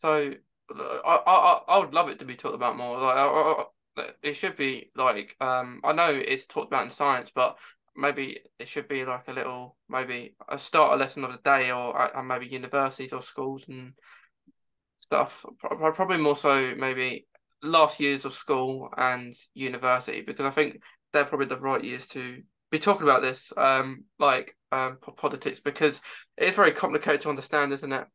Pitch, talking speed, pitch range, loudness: 135 Hz, 185 wpm, 130-145 Hz, -26 LUFS